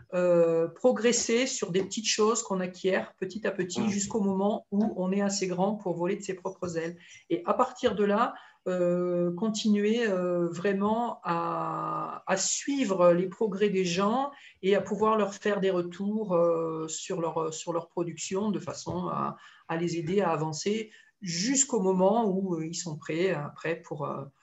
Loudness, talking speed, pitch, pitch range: -28 LUFS, 175 wpm, 190 Hz, 175-210 Hz